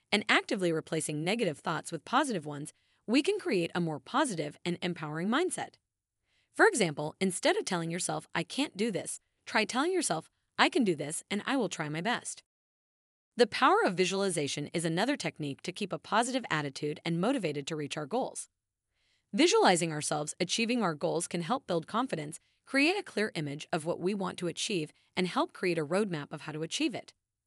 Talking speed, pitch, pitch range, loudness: 190 wpm, 175 Hz, 155-235 Hz, -31 LUFS